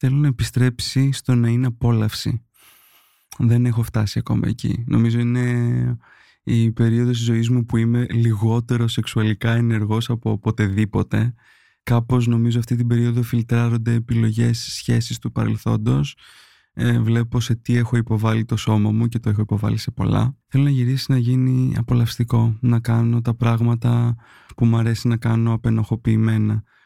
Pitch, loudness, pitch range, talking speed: 120 Hz, -20 LUFS, 115-120 Hz, 145 wpm